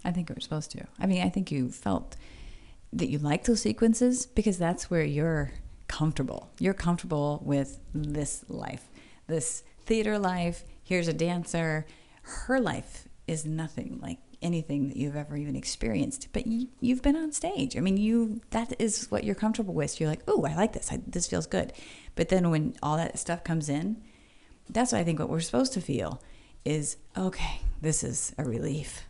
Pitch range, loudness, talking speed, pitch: 150-210 Hz, -30 LUFS, 190 wpm, 165 Hz